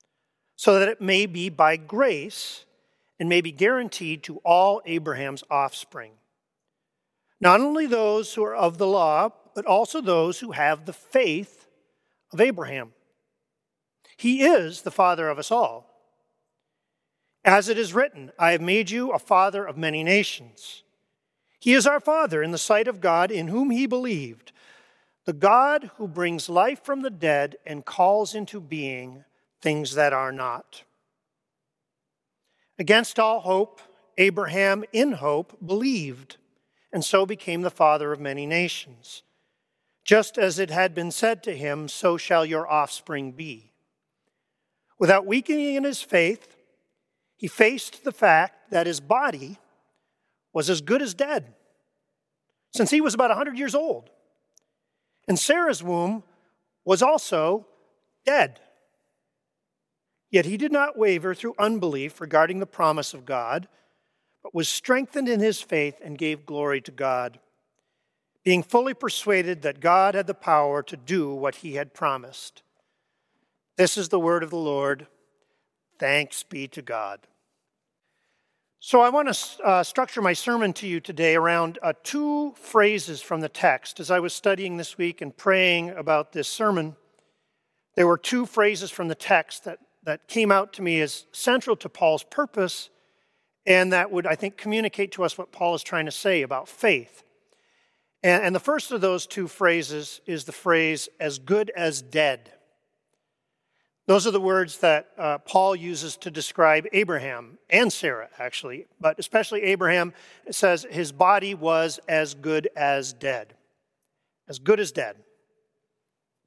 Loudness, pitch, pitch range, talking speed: -23 LUFS, 185 Hz, 155-215 Hz, 150 wpm